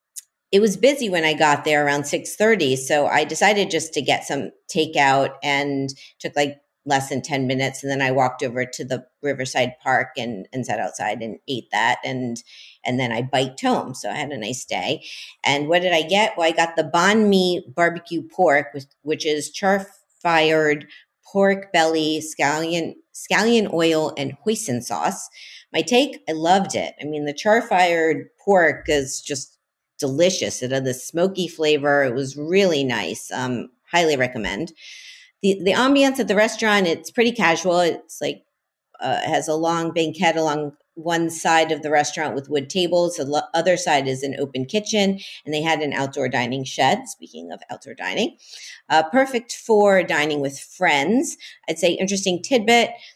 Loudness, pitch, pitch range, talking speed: -20 LUFS, 160 Hz, 140-195 Hz, 175 wpm